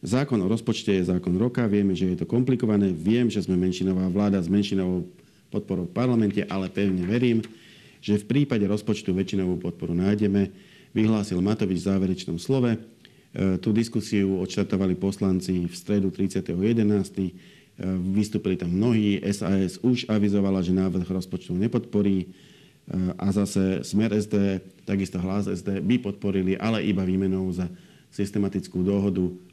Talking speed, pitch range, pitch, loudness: 145 wpm, 95-105 Hz, 100 Hz, -25 LUFS